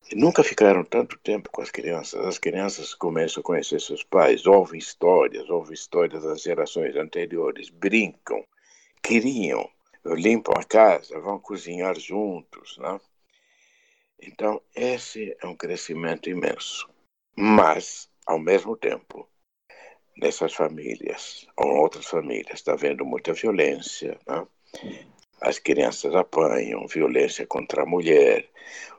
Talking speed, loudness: 120 wpm, -23 LUFS